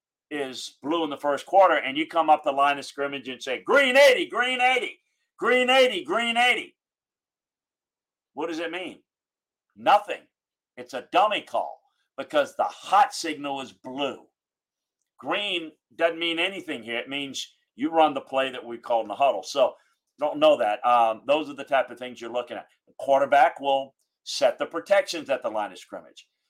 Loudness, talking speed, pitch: -24 LUFS, 185 wpm, 150 Hz